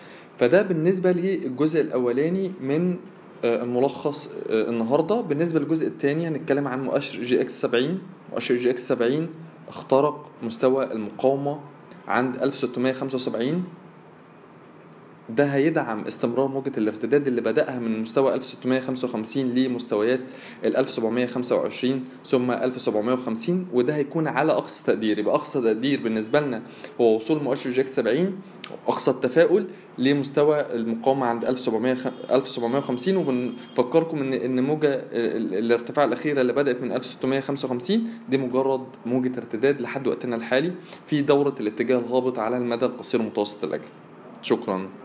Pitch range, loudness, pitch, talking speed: 125-150 Hz, -24 LUFS, 130 Hz, 120 wpm